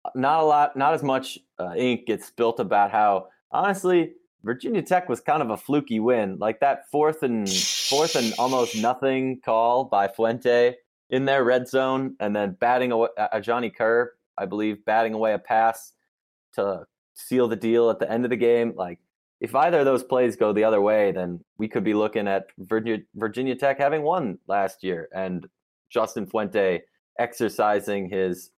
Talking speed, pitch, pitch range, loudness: 185 wpm, 115 Hz, 105-130 Hz, -23 LUFS